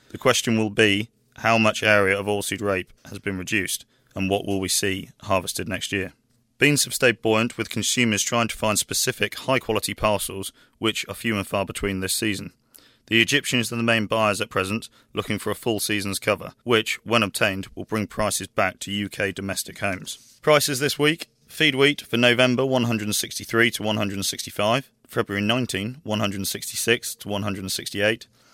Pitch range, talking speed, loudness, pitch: 100-120 Hz, 170 wpm, -23 LUFS, 110 Hz